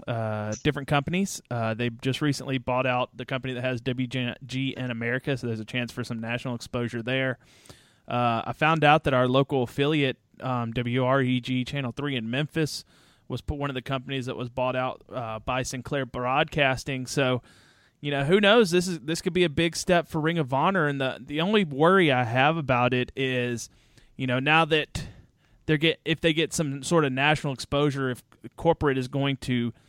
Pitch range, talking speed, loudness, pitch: 125-150 Hz, 195 wpm, -26 LUFS, 130 Hz